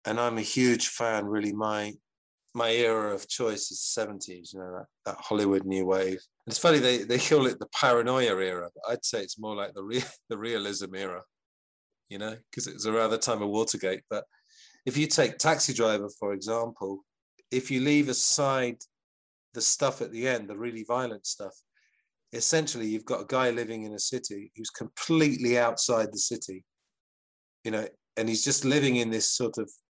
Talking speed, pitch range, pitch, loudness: 190 wpm, 100-125 Hz, 110 Hz, -28 LUFS